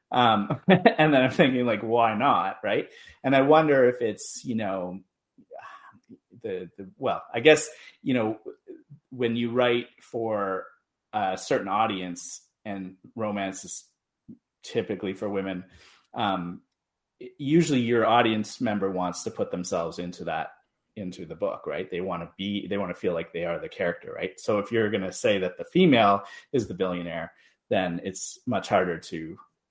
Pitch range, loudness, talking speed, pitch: 95-140 Hz, -26 LUFS, 165 wpm, 110 Hz